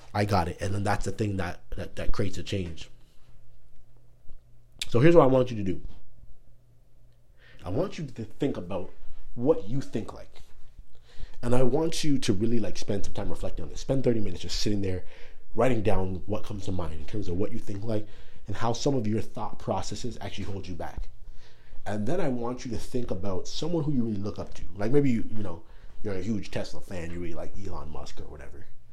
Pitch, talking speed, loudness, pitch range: 105 Hz, 220 wpm, -30 LUFS, 95-120 Hz